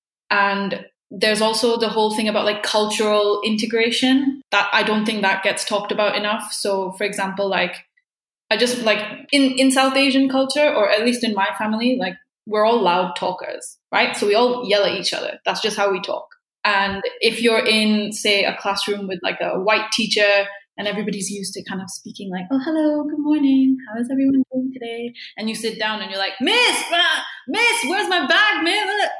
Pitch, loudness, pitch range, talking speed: 220 Hz, -19 LUFS, 205-265 Hz, 200 wpm